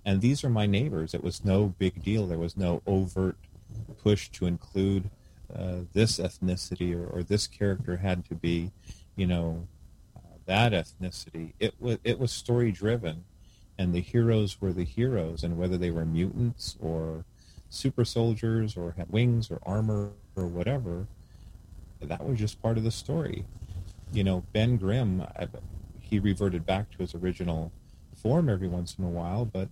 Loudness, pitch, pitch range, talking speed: -29 LUFS, 95 Hz, 90-110 Hz, 170 wpm